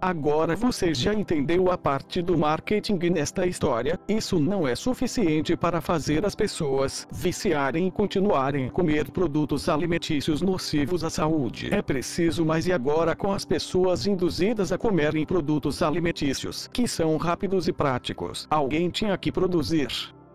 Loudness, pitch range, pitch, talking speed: -25 LUFS, 150-185 Hz, 170 Hz, 145 wpm